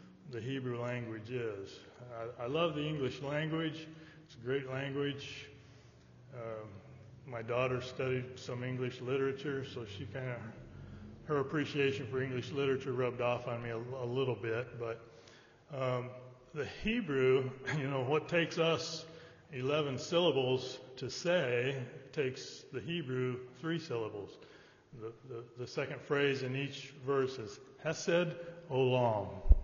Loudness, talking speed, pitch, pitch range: -36 LUFS, 135 wpm, 130 Hz, 120-140 Hz